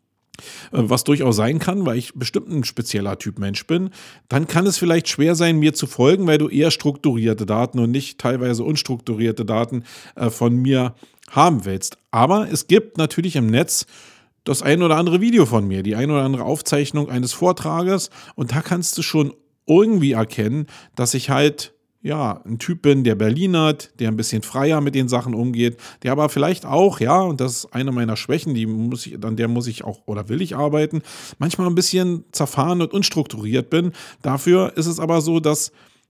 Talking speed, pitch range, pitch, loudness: 195 wpm, 120-165 Hz, 140 Hz, -19 LUFS